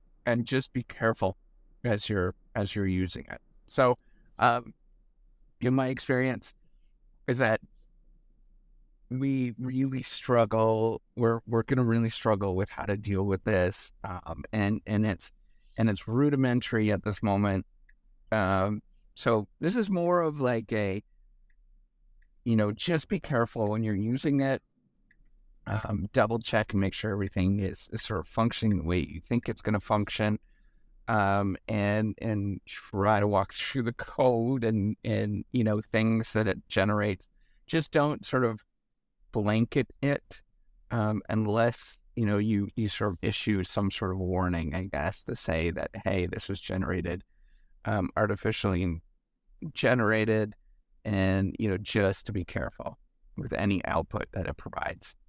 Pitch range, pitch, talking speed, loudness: 95-115 Hz, 105 Hz, 150 wpm, -29 LUFS